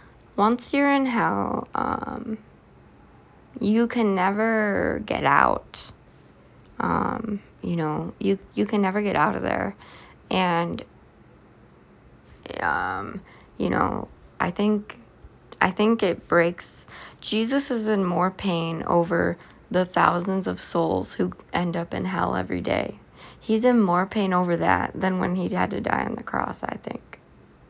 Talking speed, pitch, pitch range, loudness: 140 wpm, 195 Hz, 175-220 Hz, -24 LUFS